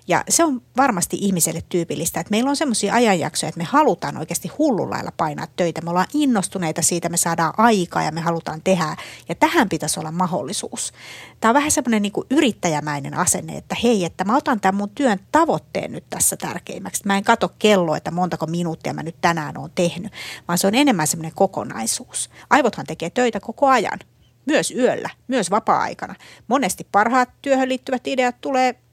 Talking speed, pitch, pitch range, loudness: 180 wpm, 195 Hz, 170-250 Hz, -20 LUFS